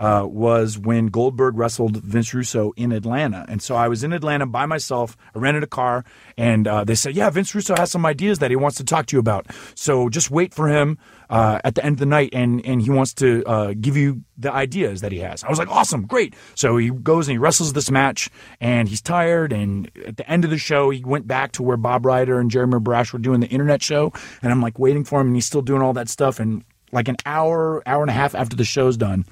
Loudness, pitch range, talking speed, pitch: -20 LUFS, 115-145 Hz, 260 wpm, 130 Hz